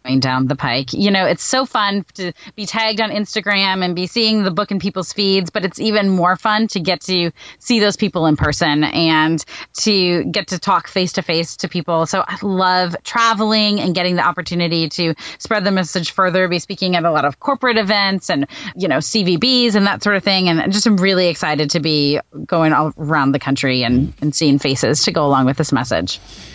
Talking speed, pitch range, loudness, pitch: 220 wpm, 155-205 Hz, -16 LUFS, 185 Hz